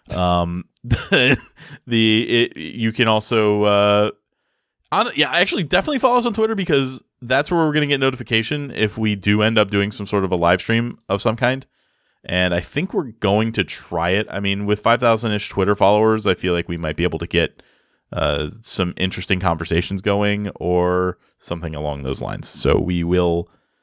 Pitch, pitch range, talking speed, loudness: 105 Hz, 90-115 Hz, 190 wpm, -19 LUFS